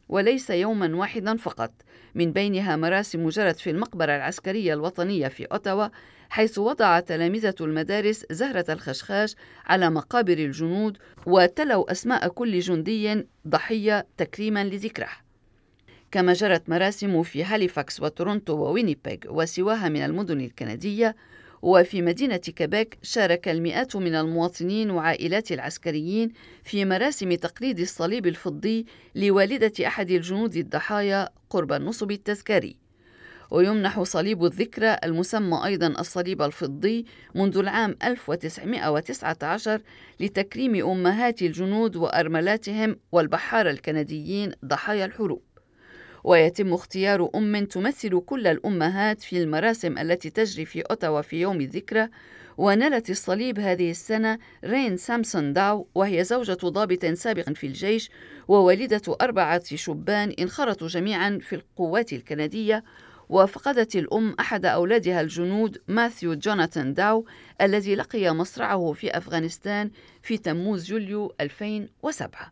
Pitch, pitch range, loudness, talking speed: 190 Hz, 170-215 Hz, -25 LUFS, 110 wpm